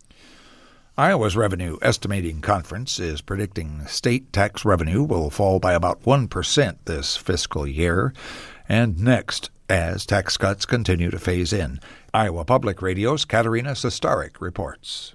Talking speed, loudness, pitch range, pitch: 130 wpm, -22 LUFS, 90-115 Hz, 100 Hz